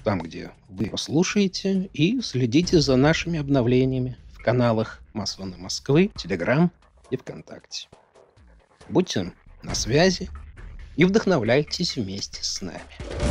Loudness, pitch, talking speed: -23 LUFS, 130 Hz, 110 wpm